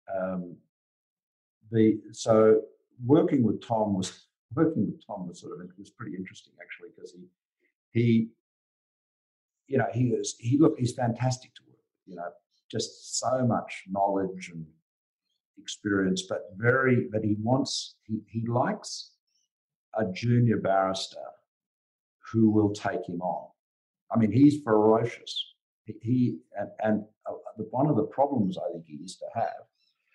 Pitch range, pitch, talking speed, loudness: 100-120 Hz, 110 Hz, 150 wpm, -27 LUFS